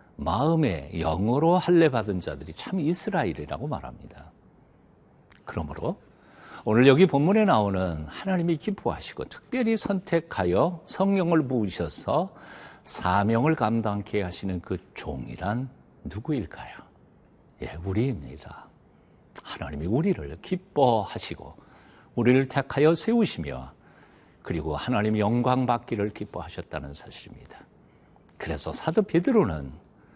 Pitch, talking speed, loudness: 120 Hz, 275 characters per minute, -26 LUFS